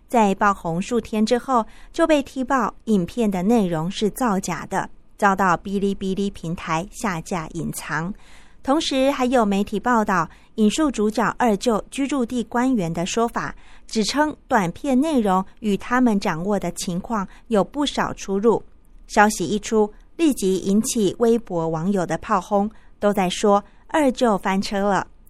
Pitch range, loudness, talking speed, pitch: 190-240 Hz, -21 LUFS, 230 characters per minute, 210 Hz